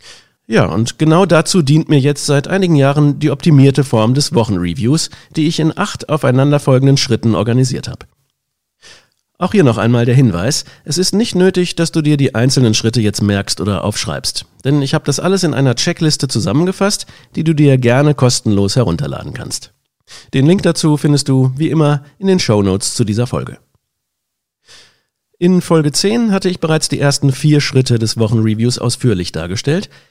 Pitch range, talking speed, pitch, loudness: 120-160 Hz, 170 wpm, 140 Hz, -13 LUFS